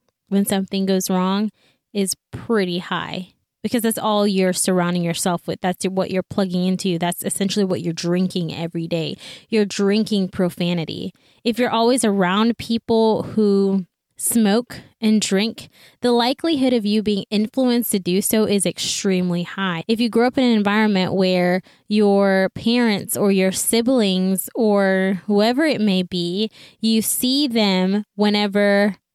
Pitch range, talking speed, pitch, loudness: 185-220 Hz, 150 wpm, 200 Hz, -19 LUFS